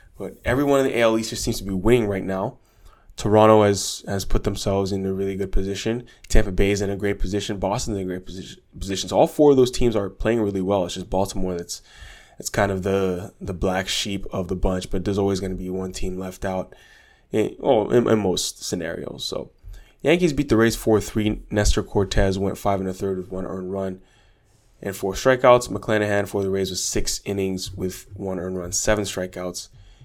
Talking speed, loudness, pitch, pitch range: 220 wpm, -23 LUFS, 100 Hz, 95-110 Hz